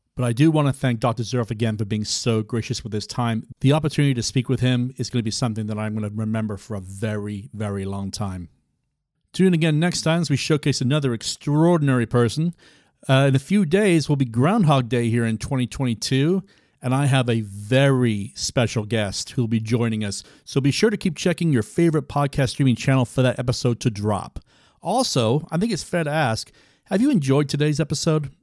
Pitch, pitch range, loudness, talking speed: 130 Hz, 110-150 Hz, -22 LUFS, 215 wpm